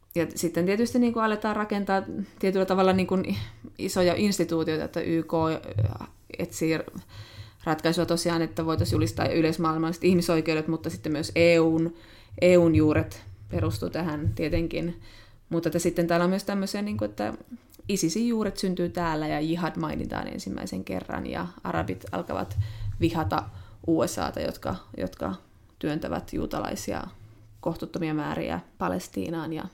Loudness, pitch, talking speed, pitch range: -27 LUFS, 165 Hz, 125 wpm, 110-175 Hz